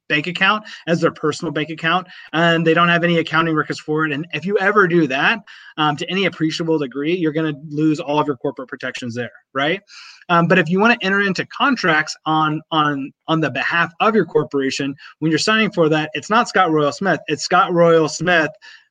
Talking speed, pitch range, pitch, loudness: 220 wpm, 150-180 Hz, 160 Hz, -18 LUFS